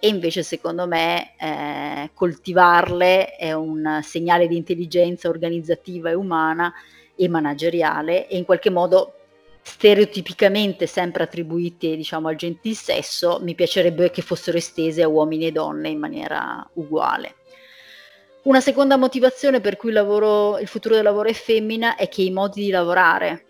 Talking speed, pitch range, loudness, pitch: 150 wpm, 170-205 Hz, -20 LUFS, 180 Hz